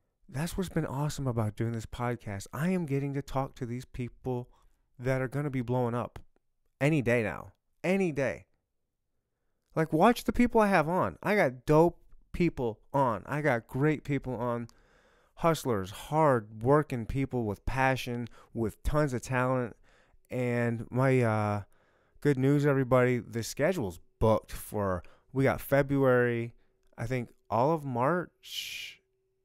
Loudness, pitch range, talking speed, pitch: -30 LUFS, 115-145 Hz, 150 wpm, 130 Hz